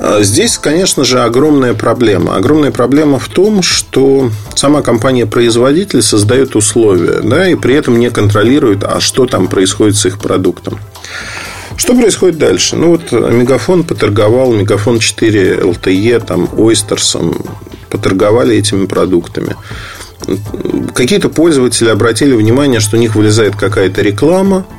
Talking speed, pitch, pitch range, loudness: 125 wpm, 120 Hz, 105-135 Hz, -9 LUFS